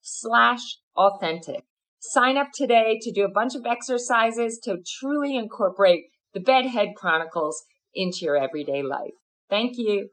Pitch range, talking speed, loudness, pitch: 185-245 Hz, 135 wpm, -23 LUFS, 220 Hz